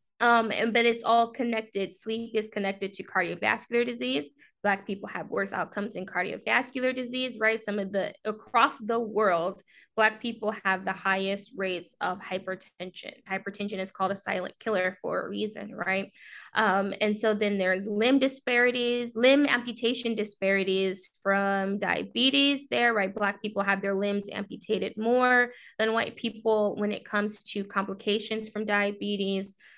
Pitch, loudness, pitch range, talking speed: 210 Hz, -27 LUFS, 195-230 Hz, 155 wpm